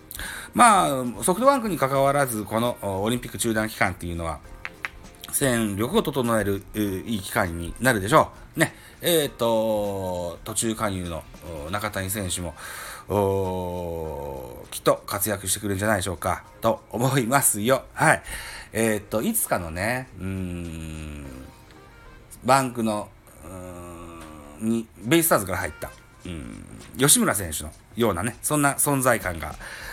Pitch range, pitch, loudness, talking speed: 90-115 Hz, 105 Hz, -24 LUFS, 265 characters per minute